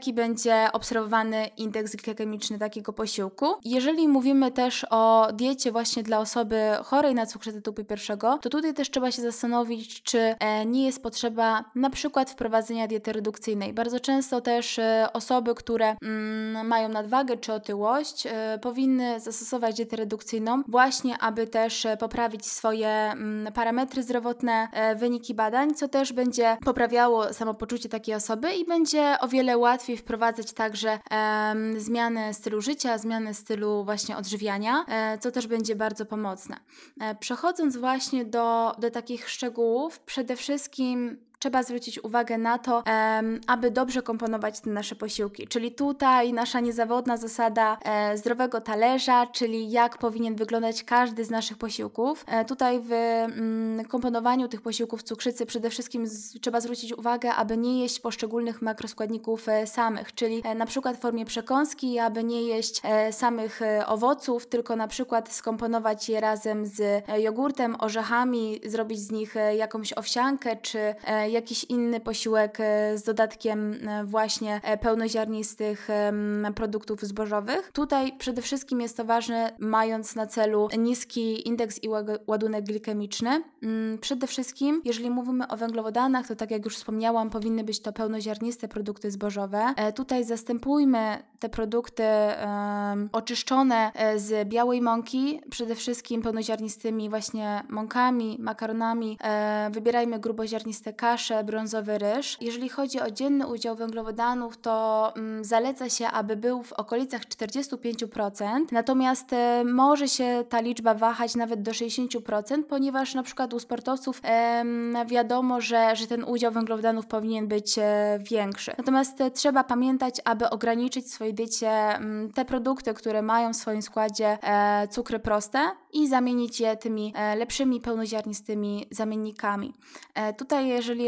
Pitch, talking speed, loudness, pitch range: 230 Hz, 130 wpm, -27 LUFS, 220-245 Hz